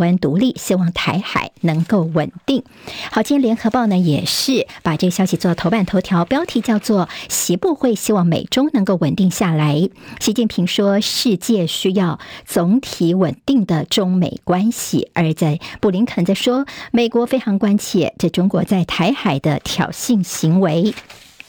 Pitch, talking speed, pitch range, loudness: 195 Hz, 245 characters per minute, 175-230 Hz, -17 LUFS